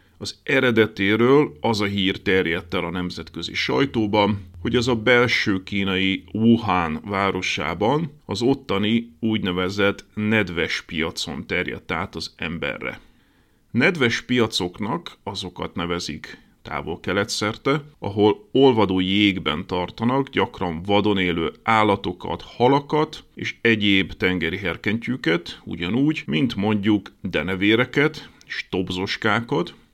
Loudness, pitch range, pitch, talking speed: -22 LUFS, 95-115 Hz, 105 Hz, 105 wpm